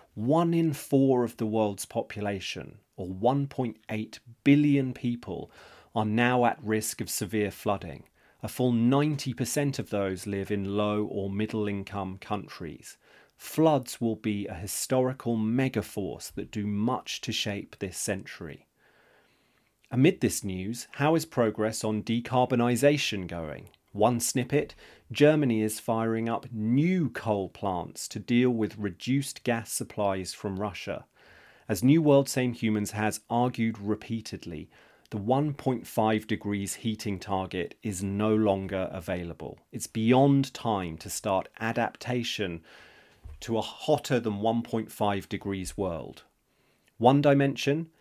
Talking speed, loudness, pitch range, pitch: 125 wpm, -28 LUFS, 100-125 Hz, 110 Hz